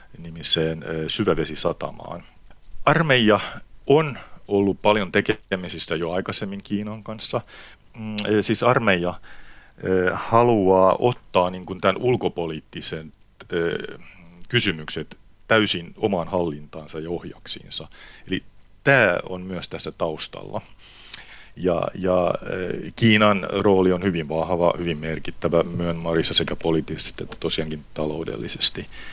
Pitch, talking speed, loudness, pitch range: 90 Hz, 95 wpm, -22 LUFS, 80-100 Hz